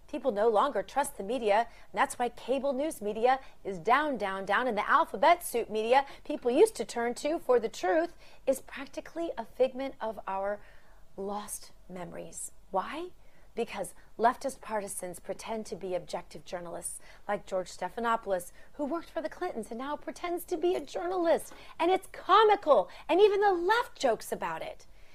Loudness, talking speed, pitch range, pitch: -30 LUFS, 170 wpm, 200-305 Hz, 240 Hz